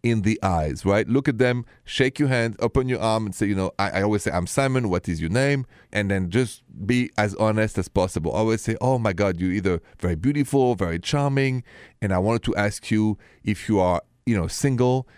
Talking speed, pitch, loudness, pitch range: 235 wpm, 110 Hz, -23 LUFS, 100-125 Hz